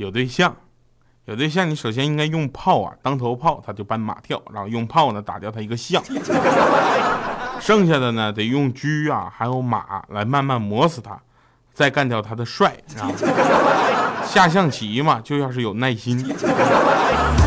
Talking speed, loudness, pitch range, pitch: 225 characters per minute, -20 LUFS, 110-150 Hz, 125 Hz